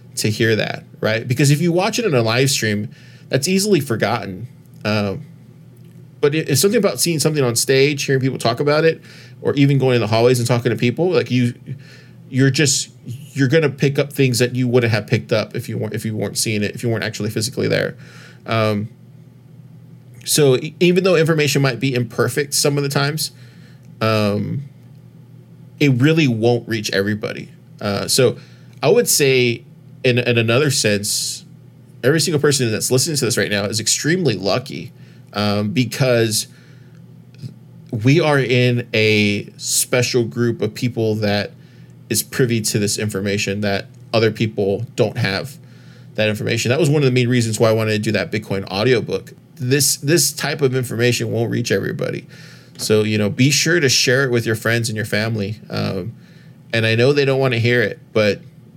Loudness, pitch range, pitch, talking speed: -17 LUFS, 110-140 Hz, 125 Hz, 185 wpm